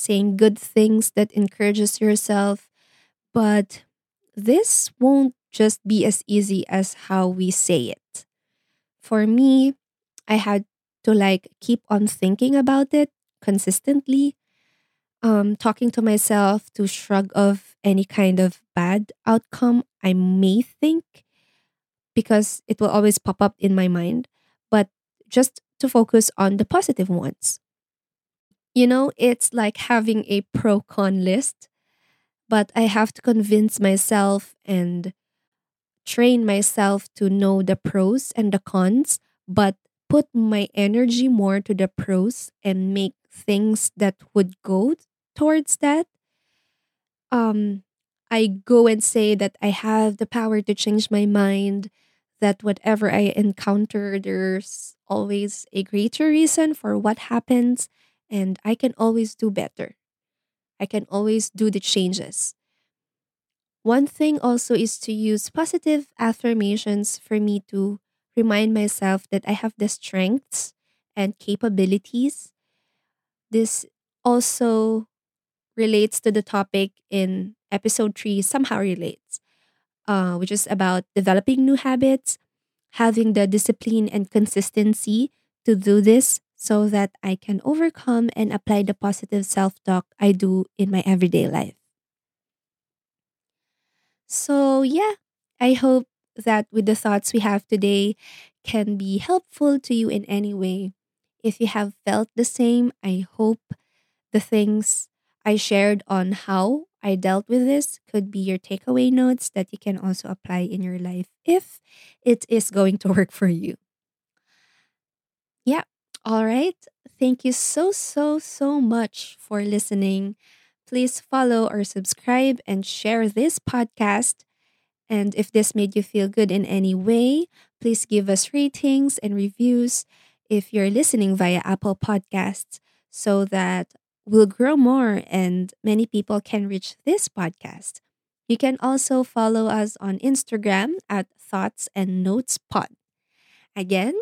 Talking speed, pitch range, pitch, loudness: 135 wpm, 195-235 Hz, 210 Hz, -21 LUFS